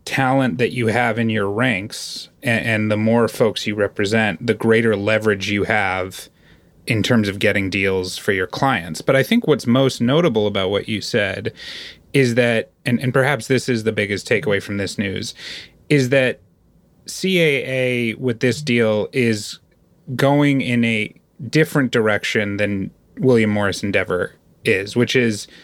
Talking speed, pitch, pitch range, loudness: 160 wpm, 115 Hz, 105-130 Hz, -19 LUFS